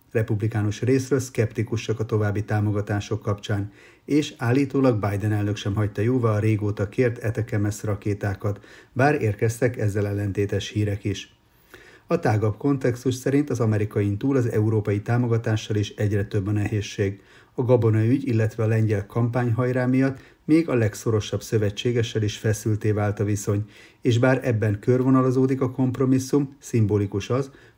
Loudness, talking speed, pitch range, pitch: -24 LUFS, 140 wpm, 105-125 Hz, 110 Hz